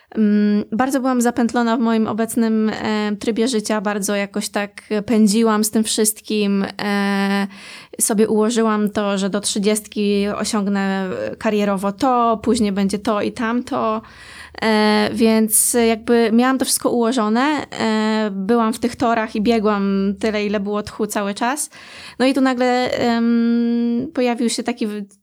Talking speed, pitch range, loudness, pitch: 140 wpm, 210-235 Hz, -18 LUFS, 220 Hz